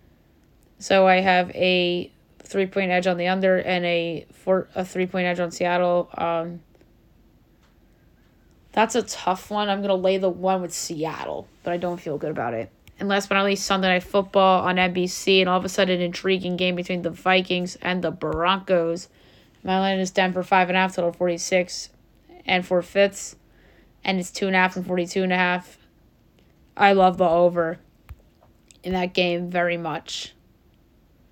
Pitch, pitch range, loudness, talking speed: 180 Hz, 175-190 Hz, -22 LUFS, 185 wpm